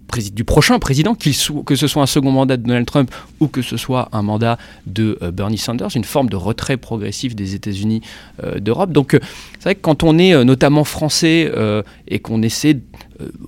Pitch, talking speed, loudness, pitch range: 125 Hz, 210 wpm, -16 LUFS, 110-150 Hz